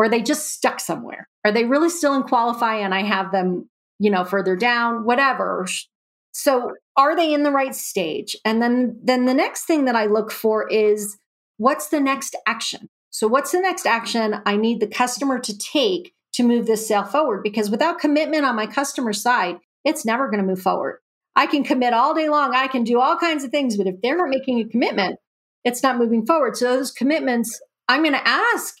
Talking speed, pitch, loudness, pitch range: 215 wpm, 250 Hz, -20 LUFS, 220-285 Hz